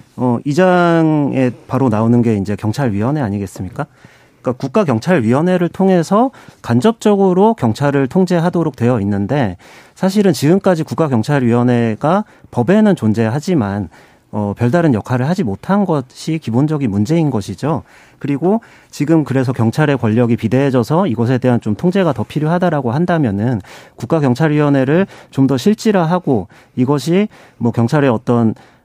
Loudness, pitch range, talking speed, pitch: -15 LUFS, 120-175 Hz, 340 characters per minute, 140 Hz